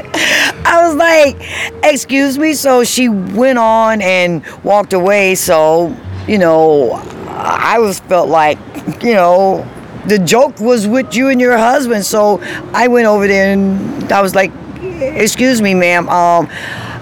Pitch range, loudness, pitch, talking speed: 185-255 Hz, -11 LUFS, 210 Hz, 150 wpm